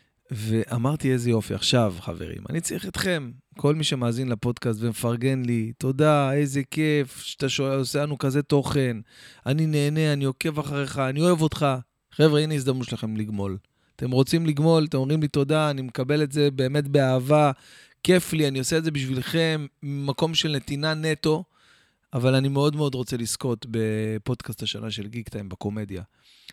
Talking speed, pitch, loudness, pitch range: 160 wpm, 135 Hz, -24 LUFS, 120-150 Hz